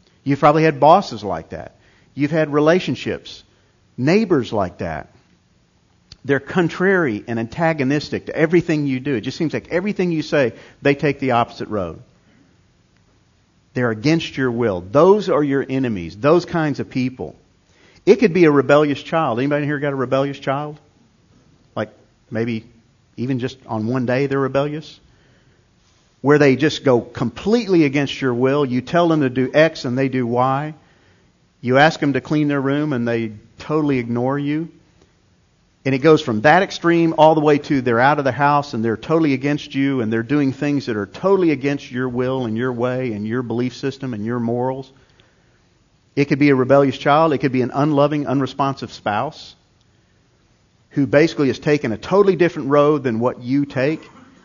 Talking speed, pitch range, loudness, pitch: 175 wpm, 120-150 Hz, -18 LUFS, 135 Hz